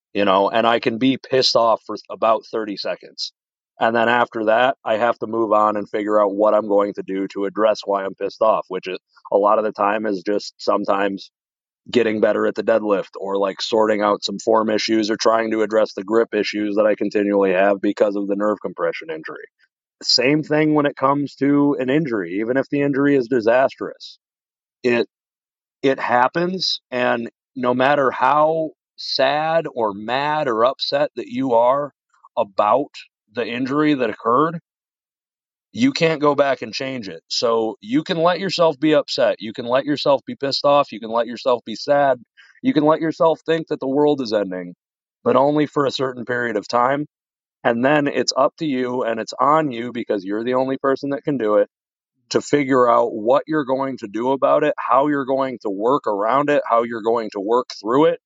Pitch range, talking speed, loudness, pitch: 110-145 Hz, 200 wpm, -19 LUFS, 125 Hz